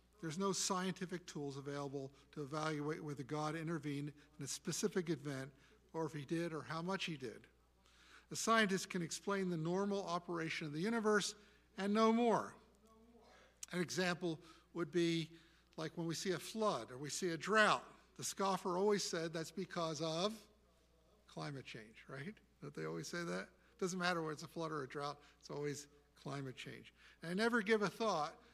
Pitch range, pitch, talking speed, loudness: 150-195 Hz, 170 Hz, 180 wpm, -40 LUFS